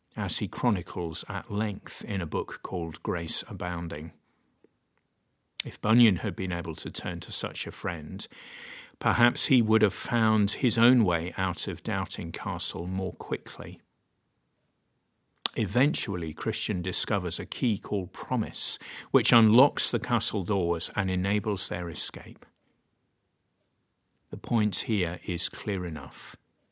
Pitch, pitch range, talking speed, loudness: 100 Hz, 90-115 Hz, 130 wpm, -28 LUFS